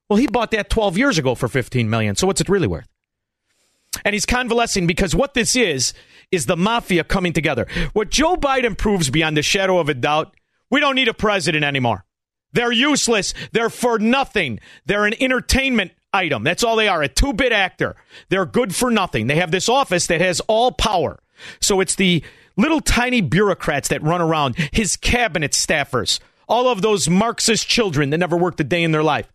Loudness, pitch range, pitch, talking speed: -18 LUFS, 165-230 Hz, 195 Hz, 200 wpm